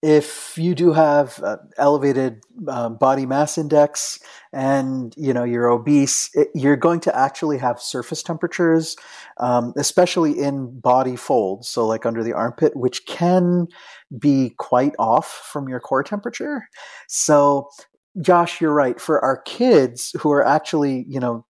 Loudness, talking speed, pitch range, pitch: -19 LUFS, 150 wpm, 125-165 Hz, 145 Hz